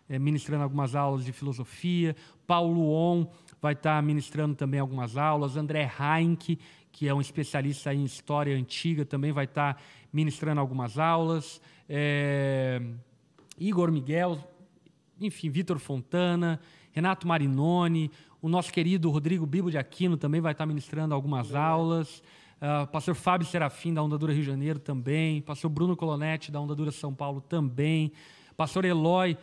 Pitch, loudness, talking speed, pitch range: 155 Hz, -29 LUFS, 150 wpm, 145-165 Hz